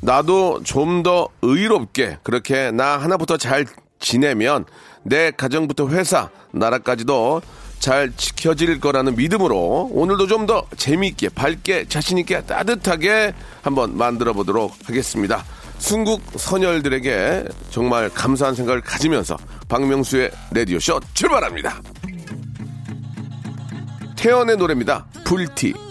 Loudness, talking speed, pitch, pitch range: -19 LUFS, 270 characters per minute, 140 Hz, 125-180 Hz